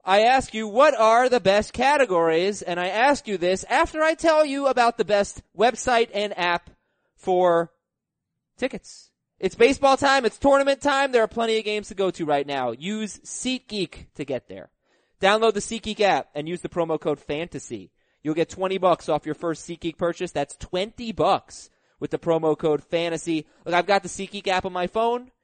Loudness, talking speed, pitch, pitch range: -23 LUFS, 195 wpm, 195 Hz, 170-235 Hz